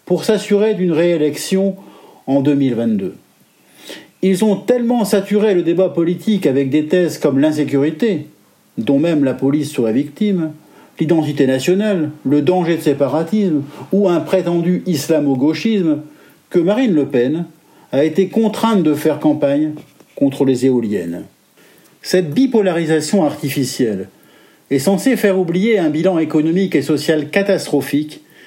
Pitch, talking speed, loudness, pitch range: 160 Hz, 125 wpm, -16 LUFS, 145-190 Hz